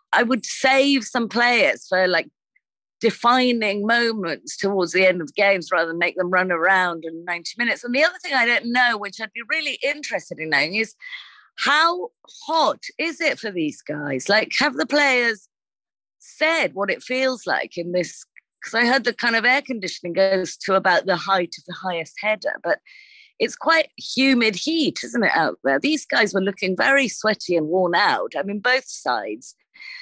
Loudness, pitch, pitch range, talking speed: -20 LUFS, 230 Hz, 185-290 Hz, 190 wpm